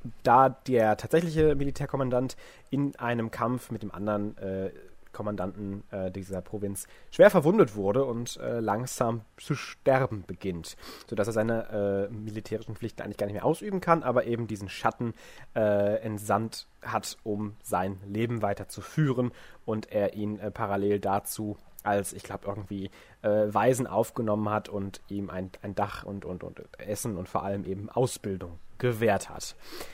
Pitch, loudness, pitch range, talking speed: 105 Hz, -29 LUFS, 100-120 Hz, 160 wpm